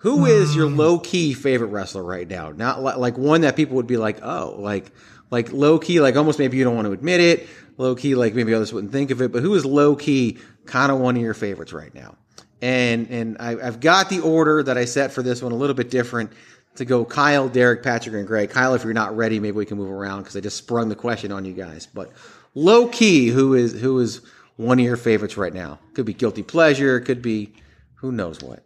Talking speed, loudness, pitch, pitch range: 250 wpm, -19 LUFS, 120 Hz, 110-140 Hz